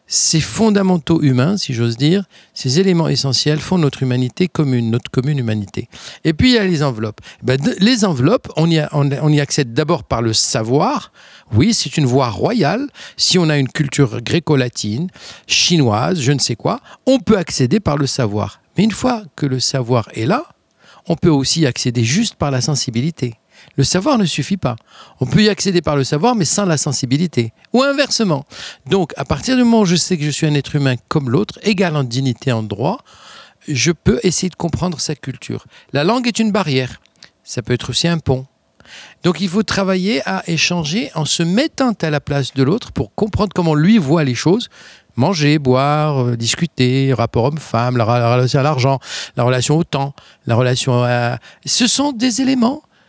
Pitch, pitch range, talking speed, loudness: 150 Hz, 130-185 Hz, 190 wpm, -16 LUFS